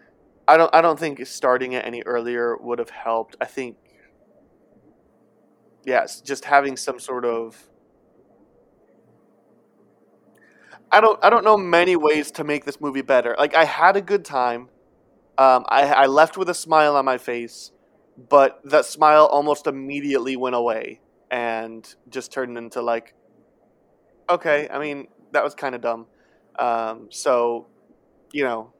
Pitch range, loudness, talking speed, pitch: 120-150 Hz, -20 LUFS, 150 wpm, 135 Hz